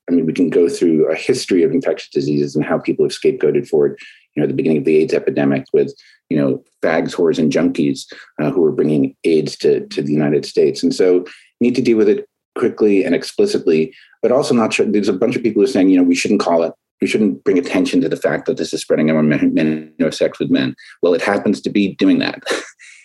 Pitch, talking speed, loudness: 380 Hz, 255 wpm, -16 LUFS